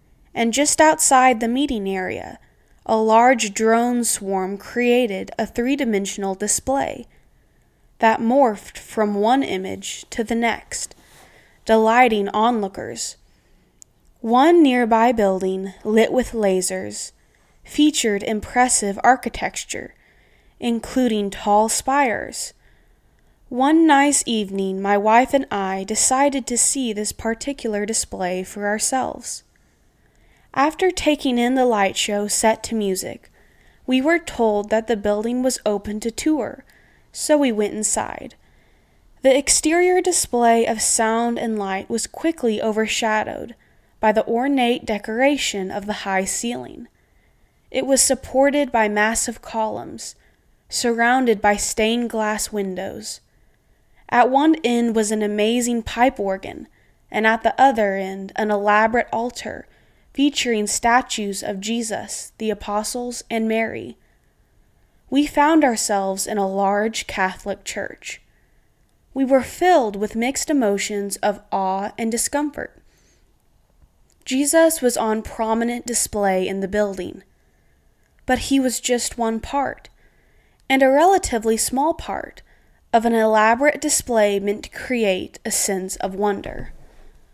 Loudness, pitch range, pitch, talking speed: -19 LUFS, 210-255 Hz, 230 Hz, 120 wpm